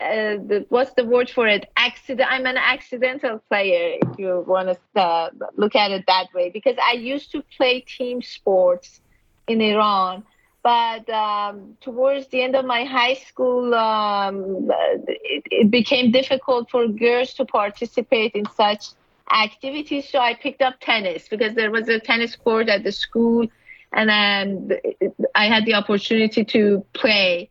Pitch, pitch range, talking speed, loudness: 230 Hz, 205-255 Hz, 165 wpm, -20 LUFS